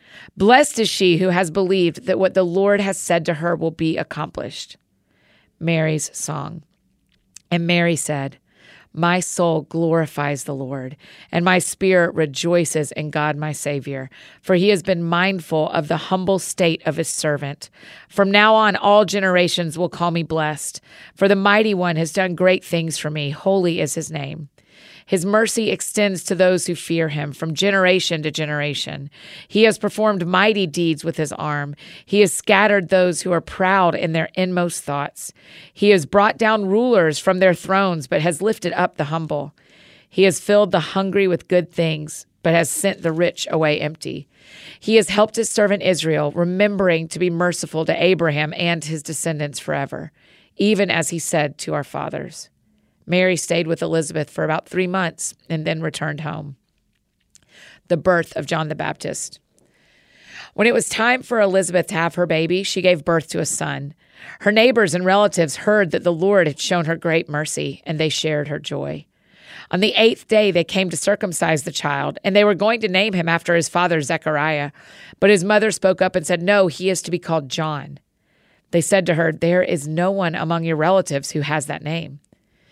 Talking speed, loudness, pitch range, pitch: 185 wpm, -19 LUFS, 155-190 Hz, 175 Hz